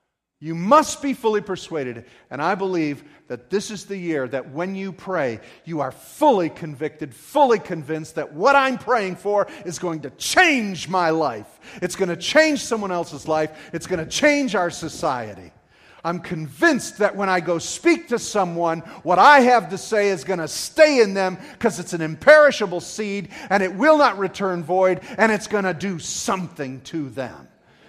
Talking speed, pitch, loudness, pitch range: 185 wpm, 185 Hz, -20 LUFS, 165-220 Hz